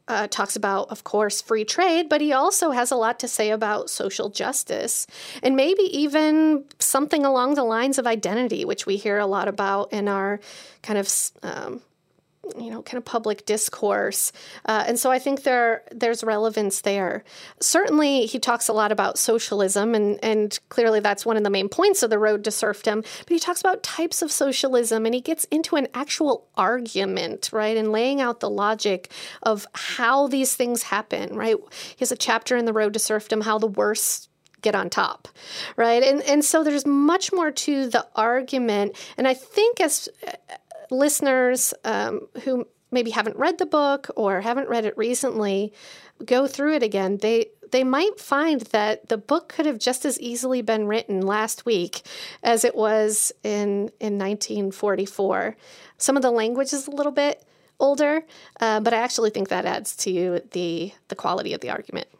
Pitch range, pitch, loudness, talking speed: 215-285 Hz, 240 Hz, -22 LUFS, 185 wpm